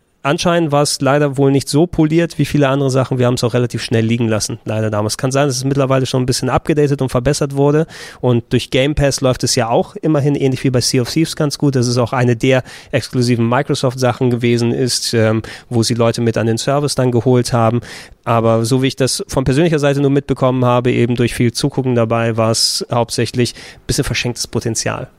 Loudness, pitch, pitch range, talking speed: -15 LUFS, 130 Hz, 120-140 Hz, 225 wpm